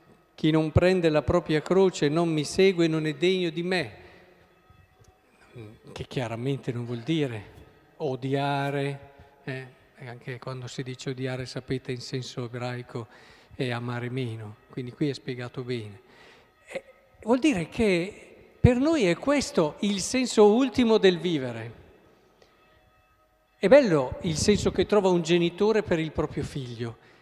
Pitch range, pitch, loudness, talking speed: 125-180 Hz, 140 Hz, -26 LUFS, 135 wpm